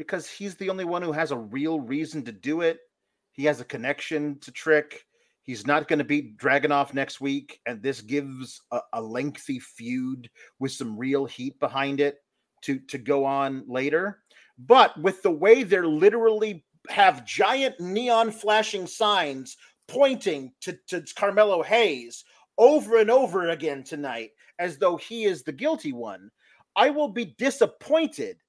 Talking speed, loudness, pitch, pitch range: 165 wpm, -24 LUFS, 160 Hz, 140-220 Hz